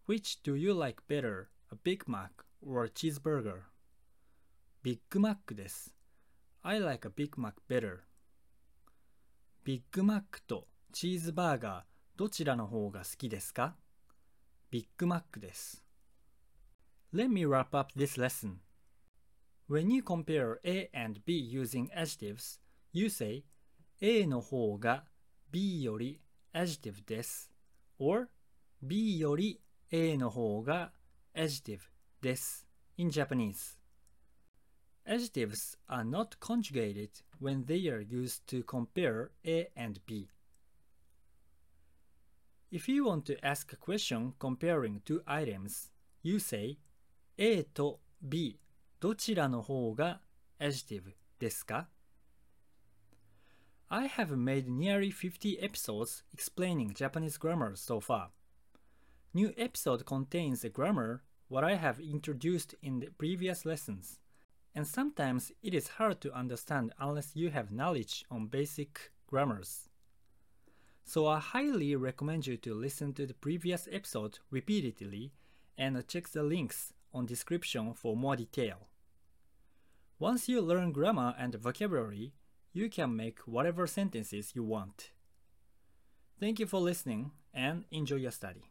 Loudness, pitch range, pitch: -36 LUFS, 105-165 Hz, 135 Hz